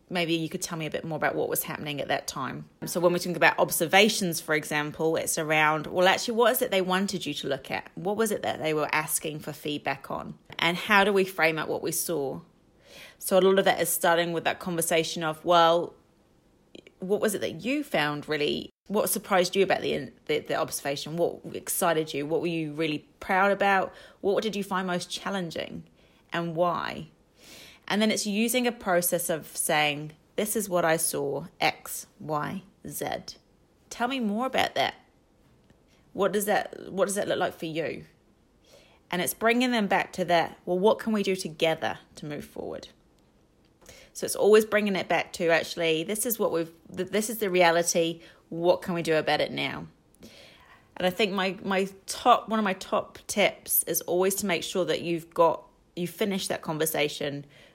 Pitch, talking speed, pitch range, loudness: 175 Hz, 200 wpm, 160-195 Hz, -27 LUFS